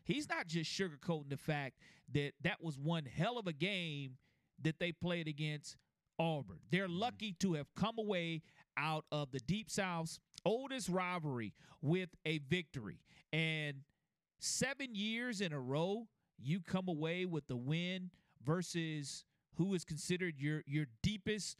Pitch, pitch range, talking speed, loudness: 165 Hz, 150-185 Hz, 150 wpm, -41 LUFS